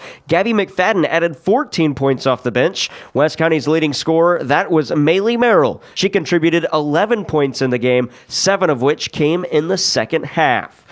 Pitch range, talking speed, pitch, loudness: 145-180 Hz, 170 wpm, 160 Hz, -16 LUFS